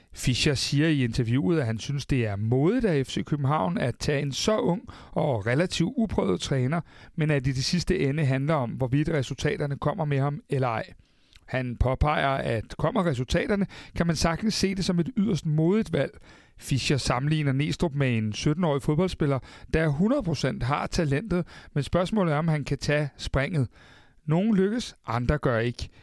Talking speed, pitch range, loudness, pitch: 180 wpm, 135-170 Hz, -26 LUFS, 150 Hz